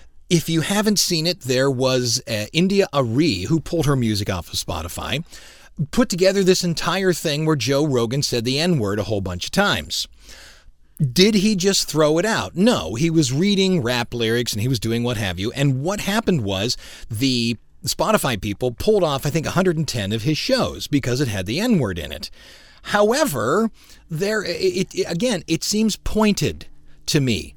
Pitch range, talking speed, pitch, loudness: 120-185 Hz, 185 wpm, 150 Hz, -20 LUFS